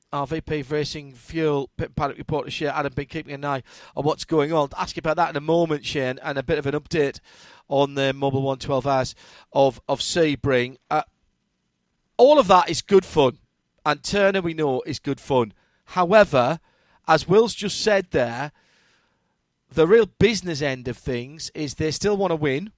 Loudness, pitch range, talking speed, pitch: -22 LUFS, 135-170 Hz, 190 wpm, 150 Hz